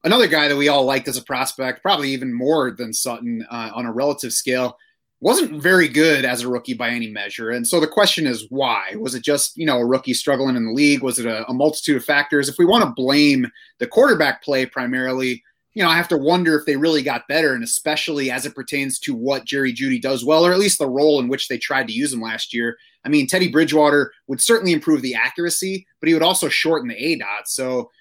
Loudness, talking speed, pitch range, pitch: -18 LUFS, 245 wpm, 130-165 Hz, 145 Hz